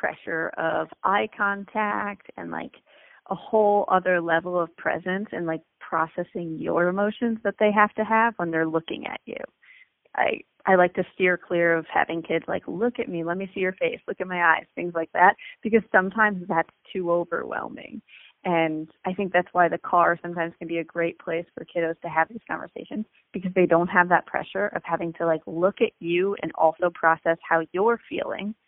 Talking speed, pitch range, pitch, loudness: 200 wpm, 165-205 Hz, 180 Hz, -24 LUFS